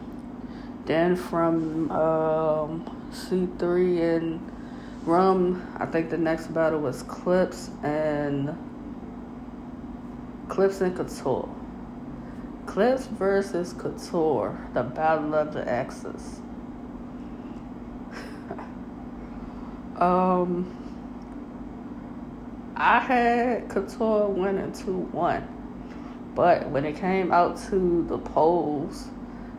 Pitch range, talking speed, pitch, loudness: 175-250 Hz, 80 wpm, 240 Hz, -25 LUFS